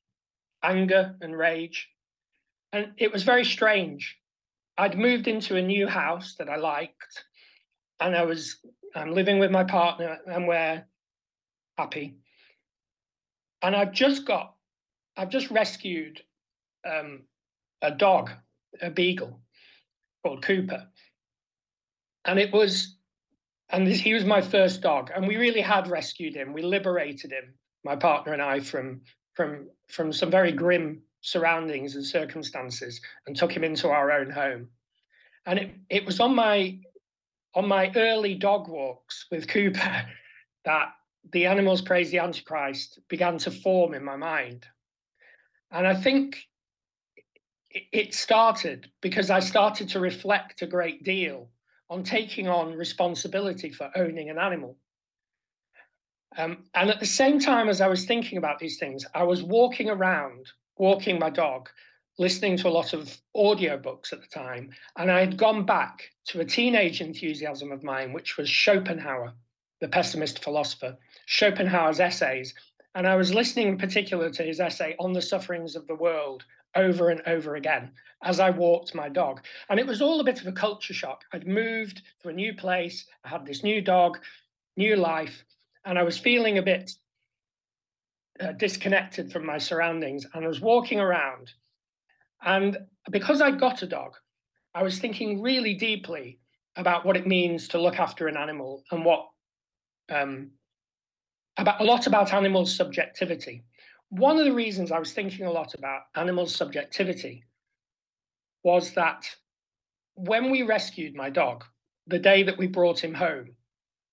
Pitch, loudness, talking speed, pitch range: 180 Hz, -26 LUFS, 155 wpm, 155-195 Hz